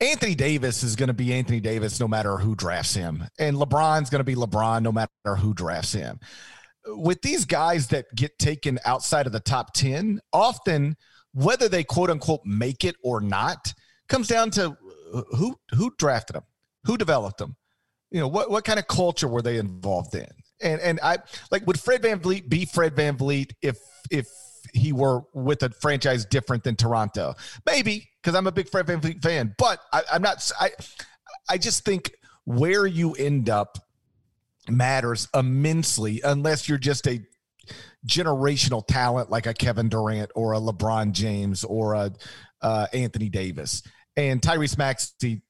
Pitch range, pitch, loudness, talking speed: 110-155 Hz, 130 Hz, -24 LUFS, 170 wpm